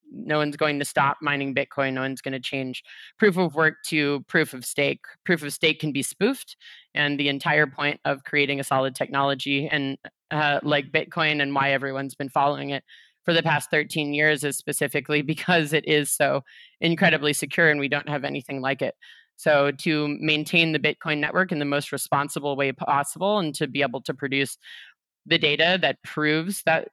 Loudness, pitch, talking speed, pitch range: -23 LUFS, 150 Hz, 195 wpm, 140-160 Hz